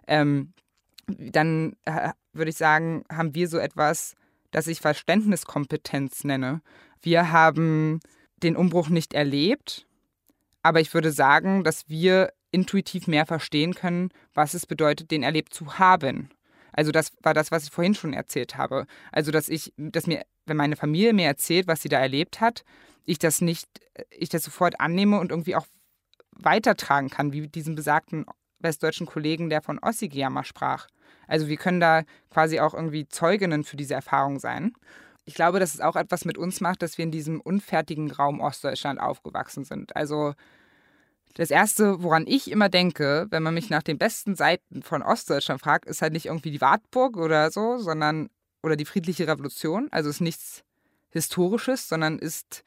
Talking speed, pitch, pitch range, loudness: 170 wpm, 160 Hz, 155-180 Hz, -24 LUFS